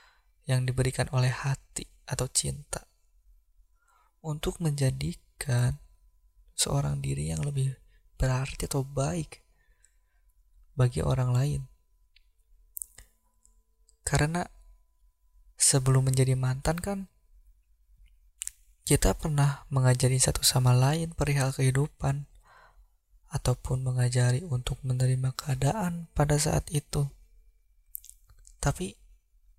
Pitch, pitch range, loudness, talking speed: 125 Hz, 85-140 Hz, -28 LUFS, 80 wpm